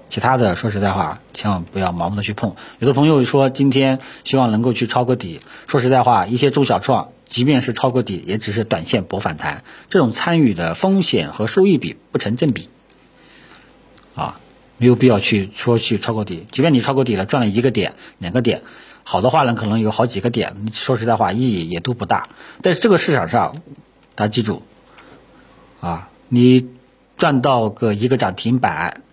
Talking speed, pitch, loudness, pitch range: 280 characters per minute, 120 Hz, -17 LUFS, 110-130 Hz